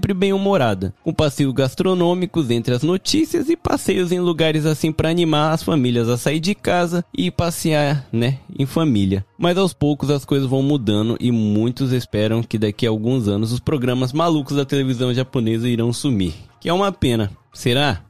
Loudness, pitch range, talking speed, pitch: -19 LUFS, 120-170 Hz, 180 wpm, 140 Hz